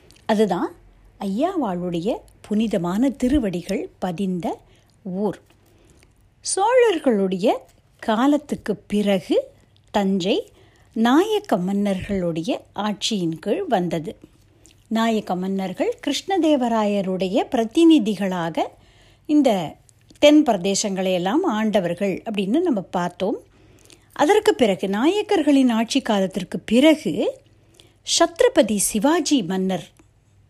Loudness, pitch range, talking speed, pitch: -21 LUFS, 195-295 Hz, 70 wpm, 220 Hz